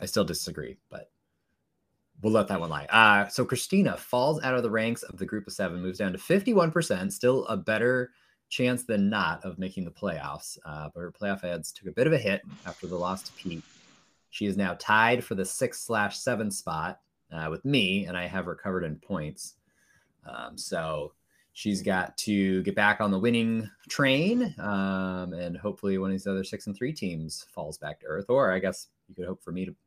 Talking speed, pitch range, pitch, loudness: 215 wpm, 90-125 Hz, 100 Hz, -28 LUFS